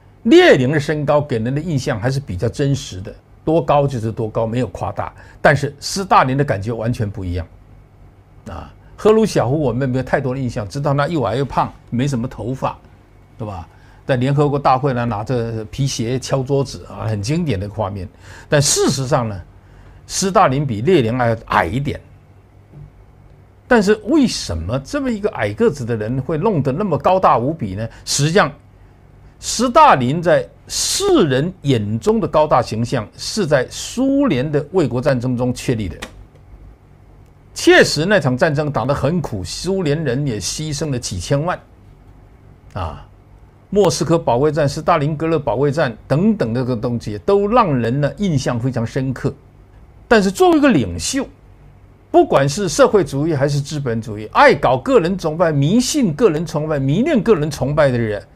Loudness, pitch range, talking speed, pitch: -17 LUFS, 110-155 Hz, 255 characters per minute, 135 Hz